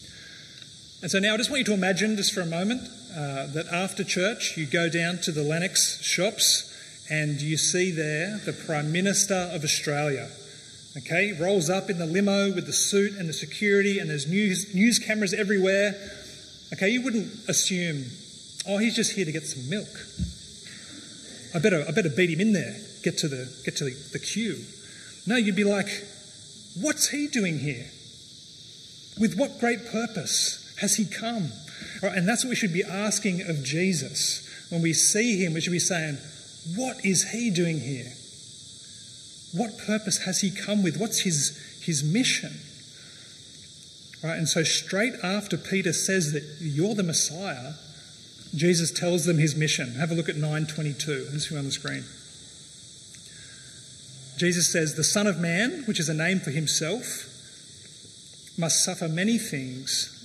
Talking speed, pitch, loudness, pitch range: 170 wpm, 175 Hz, -25 LUFS, 150-200 Hz